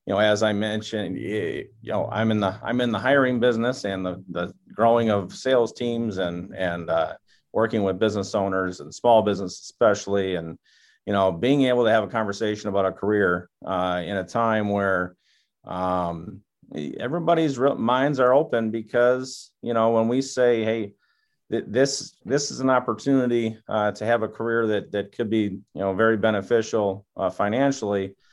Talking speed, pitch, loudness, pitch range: 180 wpm, 110 Hz, -23 LUFS, 95-120 Hz